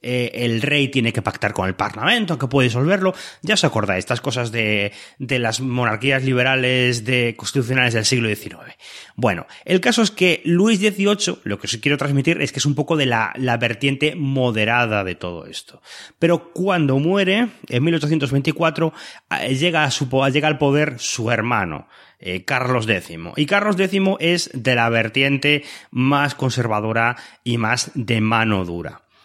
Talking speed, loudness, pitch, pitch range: 165 wpm, -19 LUFS, 130 Hz, 115-155 Hz